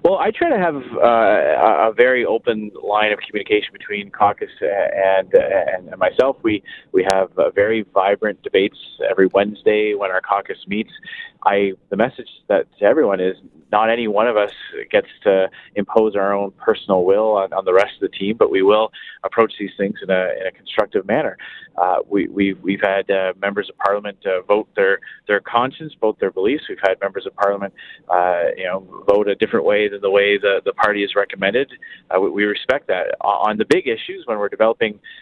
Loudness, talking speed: -18 LUFS, 200 wpm